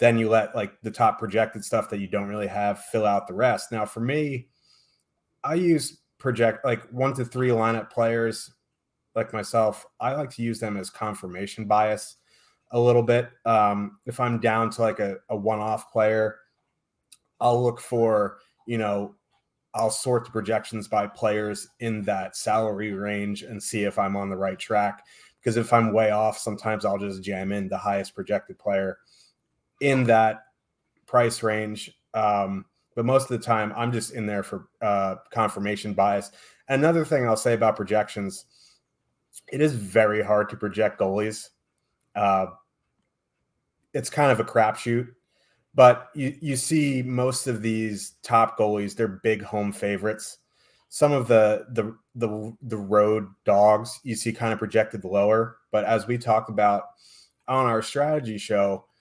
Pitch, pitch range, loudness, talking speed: 110 Hz, 105-120 Hz, -24 LUFS, 165 wpm